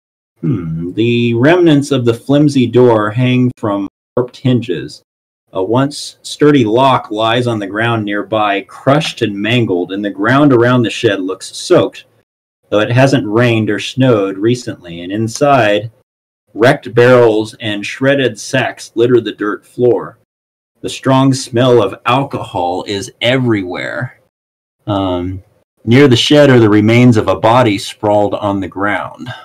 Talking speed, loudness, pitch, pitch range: 145 wpm, -12 LUFS, 115 Hz, 105-125 Hz